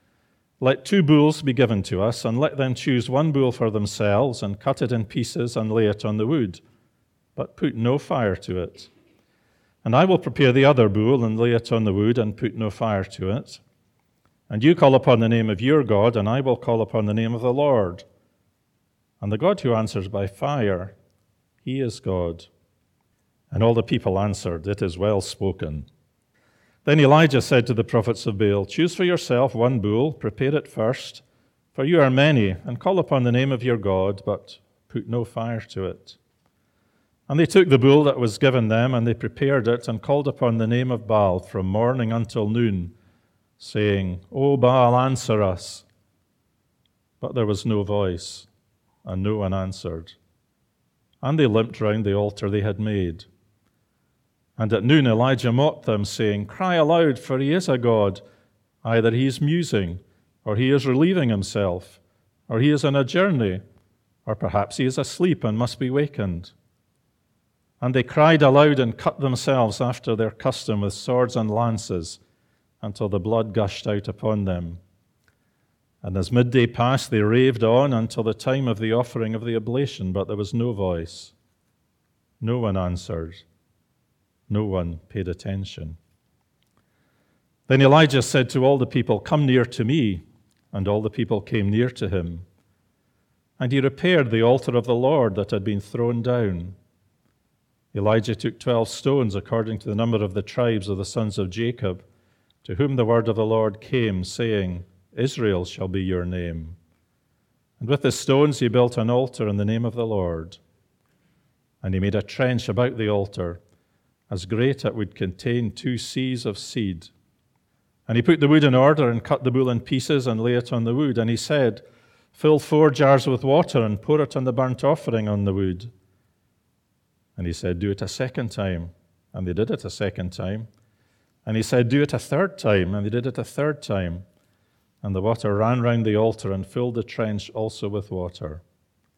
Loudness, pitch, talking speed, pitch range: -22 LUFS, 115 Hz, 185 wpm, 100-130 Hz